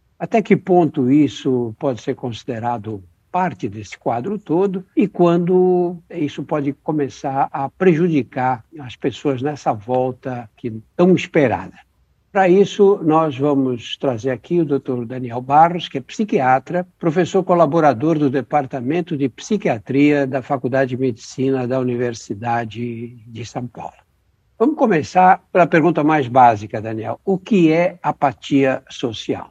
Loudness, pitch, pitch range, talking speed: -18 LUFS, 140 Hz, 125-175 Hz, 130 wpm